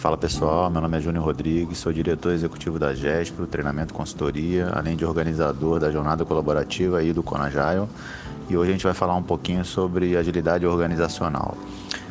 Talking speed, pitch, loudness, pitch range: 170 wpm, 85 Hz, -24 LUFS, 80-90 Hz